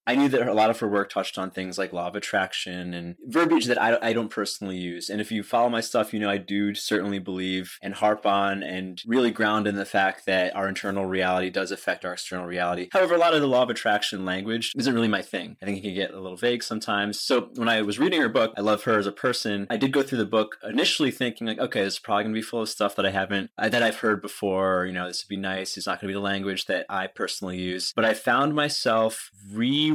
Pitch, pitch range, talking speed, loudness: 100 Hz, 95-115 Hz, 270 wpm, -25 LUFS